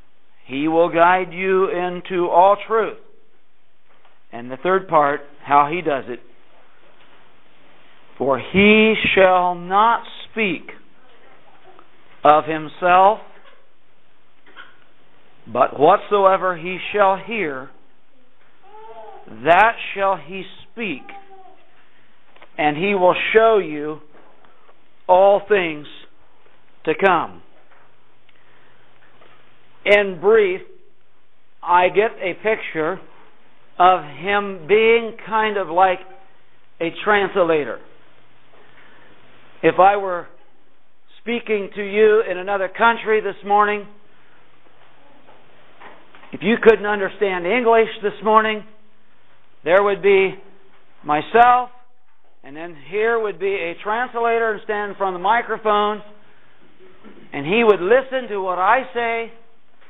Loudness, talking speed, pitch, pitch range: -18 LUFS, 95 wpm, 200 Hz, 180-220 Hz